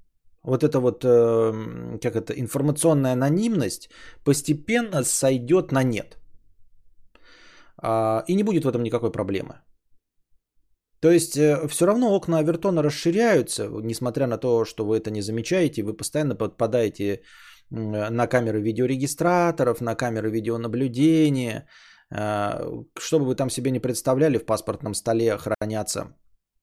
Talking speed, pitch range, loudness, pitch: 115 wpm, 110-145 Hz, -23 LUFS, 120 Hz